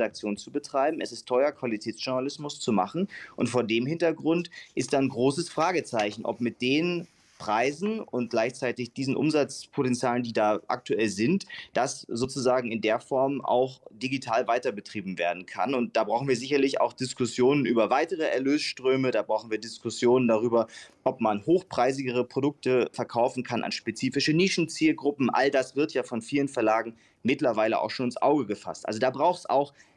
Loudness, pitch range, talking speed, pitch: -27 LUFS, 115-140 Hz, 160 wpm, 130 Hz